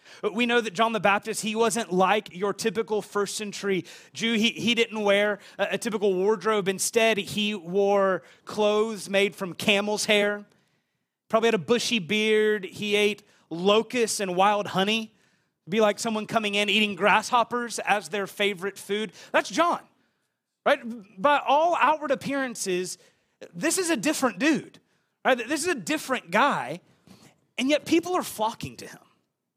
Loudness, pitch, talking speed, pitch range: -25 LUFS, 215 Hz, 155 wpm, 200-230 Hz